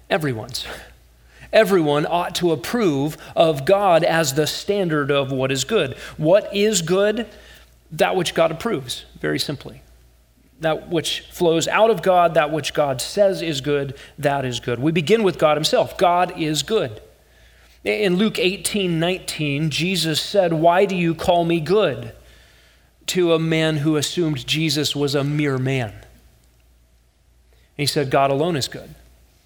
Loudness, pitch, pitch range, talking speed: -20 LUFS, 155 Hz, 130-175 Hz, 150 wpm